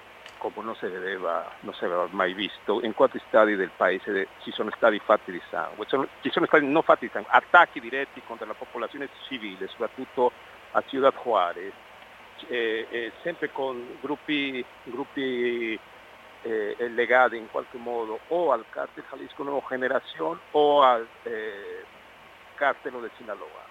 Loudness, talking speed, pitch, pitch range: -26 LUFS, 145 wpm, 130 Hz, 120-155 Hz